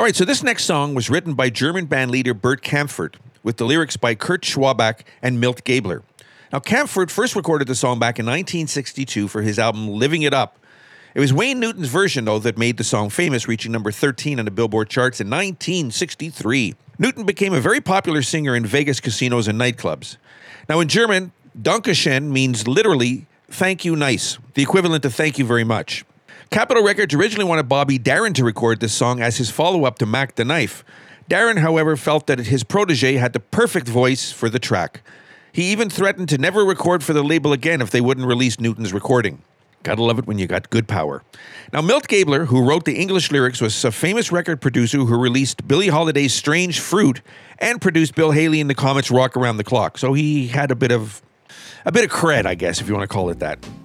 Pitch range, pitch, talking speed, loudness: 120-160 Hz, 135 Hz, 210 wpm, -18 LUFS